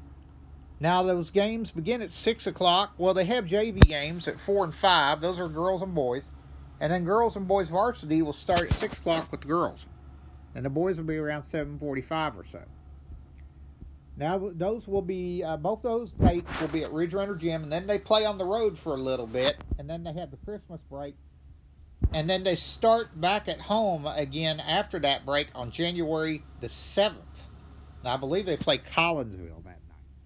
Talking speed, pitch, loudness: 190 wpm, 160 Hz, -27 LUFS